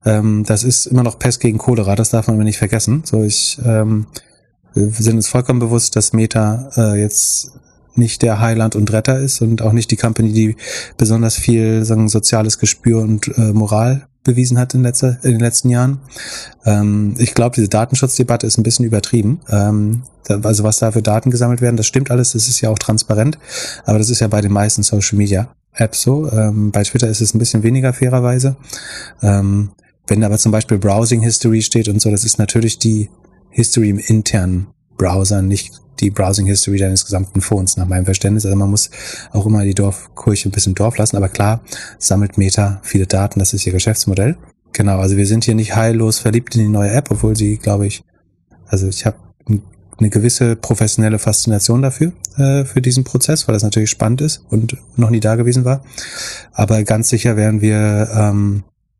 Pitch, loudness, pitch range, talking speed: 110 Hz, -14 LUFS, 105-120 Hz, 195 wpm